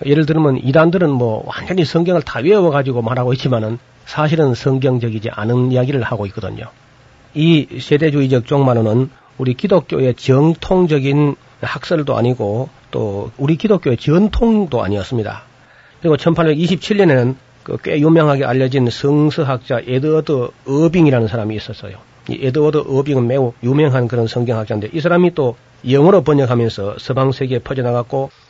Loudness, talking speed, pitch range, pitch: -15 LUFS, 355 characters per minute, 120-155 Hz, 135 Hz